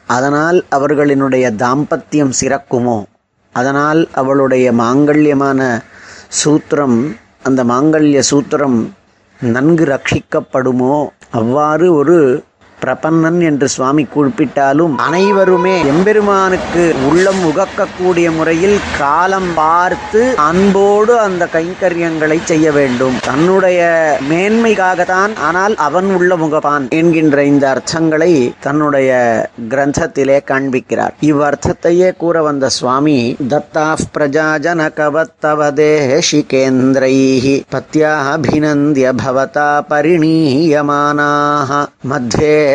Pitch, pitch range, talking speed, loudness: 150 Hz, 135-165 Hz, 80 wpm, -12 LUFS